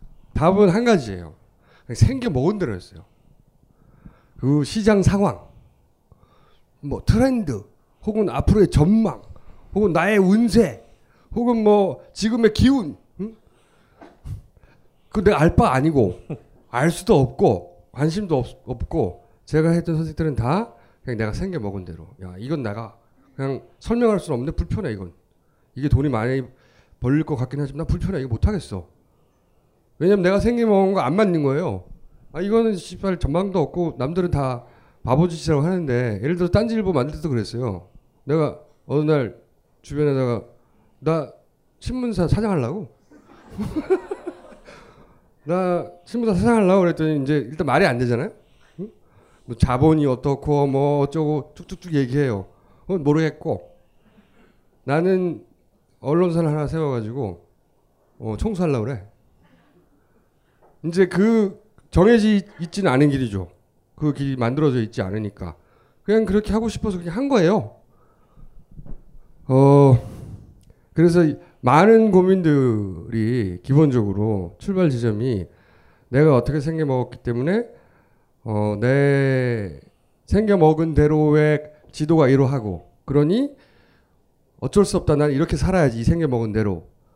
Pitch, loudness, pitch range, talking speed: 145 Hz, -20 LUFS, 120-180 Hz, 270 characters per minute